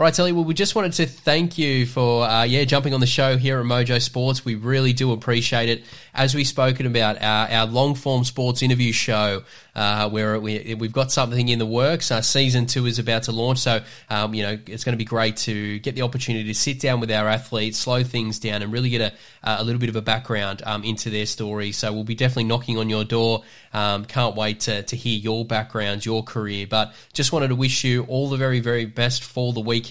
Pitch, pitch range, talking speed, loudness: 120 Hz, 110-130 Hz, 240 wpm, -21 LUFS